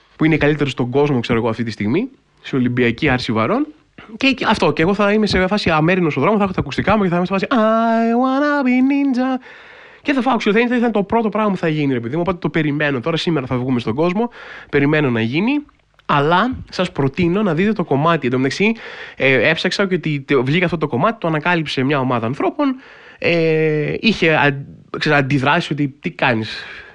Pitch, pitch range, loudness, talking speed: 170 Hz, 145-220 Hz, -17 LUFS, 210 wpm